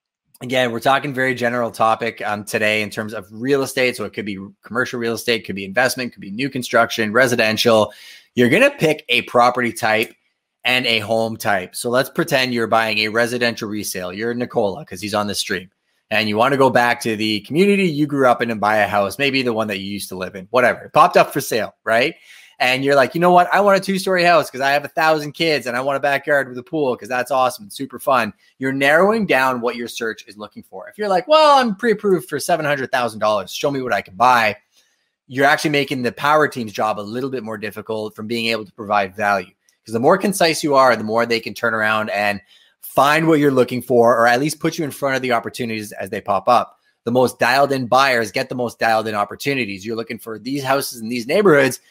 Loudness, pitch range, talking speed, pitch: -18 LUFS, 110-140 Hz, 245 wpm, 120 Hz